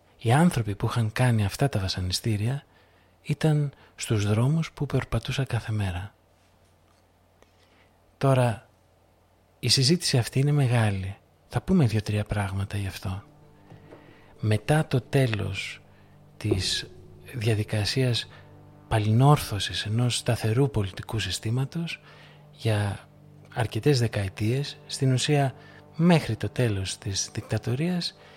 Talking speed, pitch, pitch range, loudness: 100 wpm, 115 Hz, 100-140 Hz, -26 LUFS